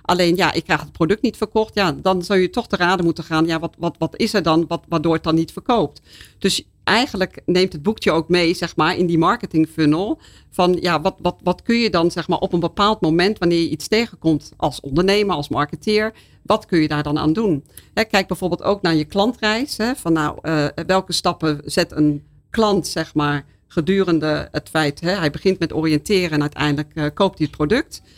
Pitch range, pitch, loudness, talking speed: 155-190 Hz, 170 Hz, -19 LUFS, 225 wpm